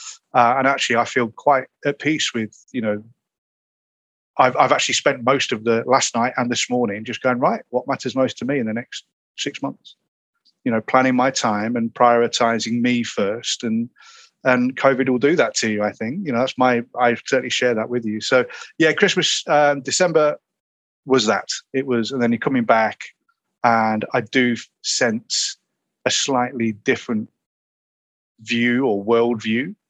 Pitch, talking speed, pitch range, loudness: 125 Hz, 180 wpm, 115-135 Hz, -19 LUFS